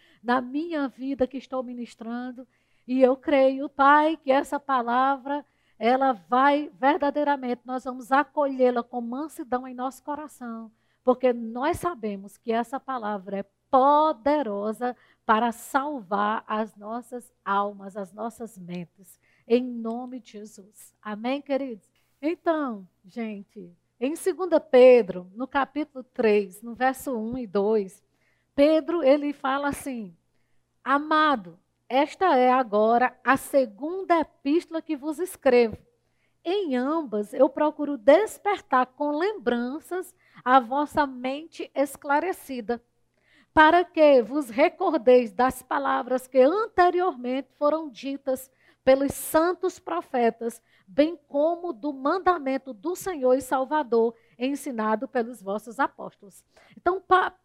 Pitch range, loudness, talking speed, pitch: 235-295 Hz, -25 LUFS, 115 wpm, 265 Hz